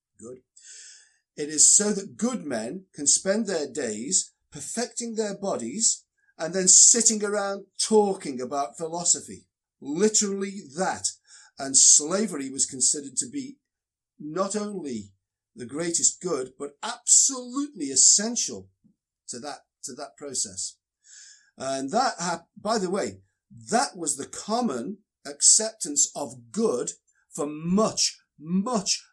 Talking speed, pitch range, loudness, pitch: 120 wpm, 140-220 Hz, -22 LUFS, 190 Hz